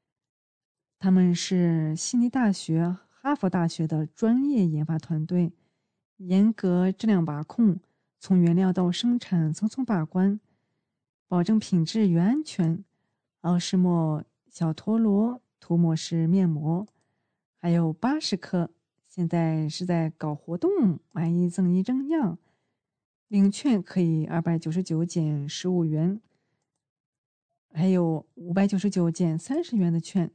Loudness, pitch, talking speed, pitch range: -25 LUFS, 175 Hz, 190 characters per minute, 165-200 Hz